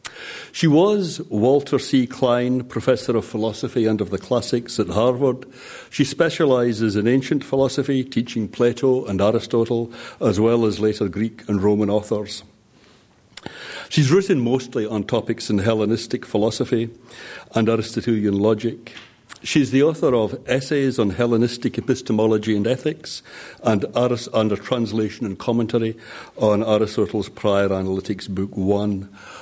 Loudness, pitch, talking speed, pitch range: -21 LUFS, 115 Hz, 130 wpm, 110-125 Hz